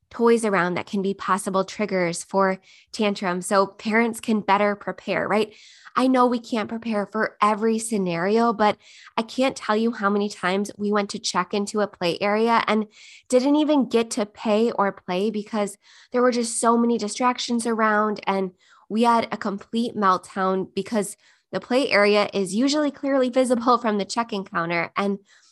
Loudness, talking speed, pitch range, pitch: -23 LUFS, 175 wpm, 195-230 Hz, 210 Hz